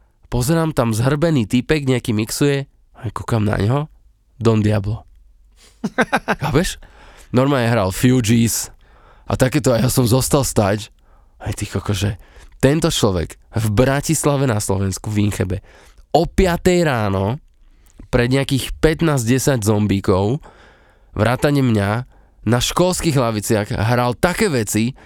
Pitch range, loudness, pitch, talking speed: 105-135 Hz, -18 LUFS, 120 Hz, 115 wpm